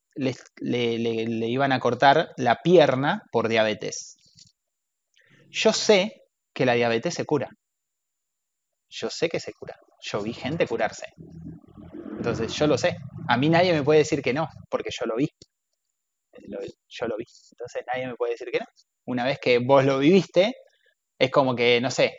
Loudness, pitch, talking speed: -23 LUFS, 145 Hz, 170 wpm